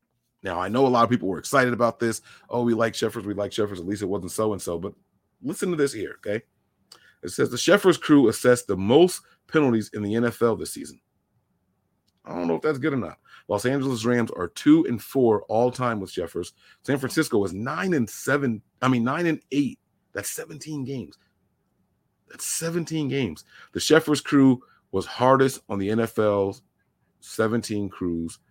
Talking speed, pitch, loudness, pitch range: 190 wpm, 120 Hz, -24 LUFS, 105-140 Hz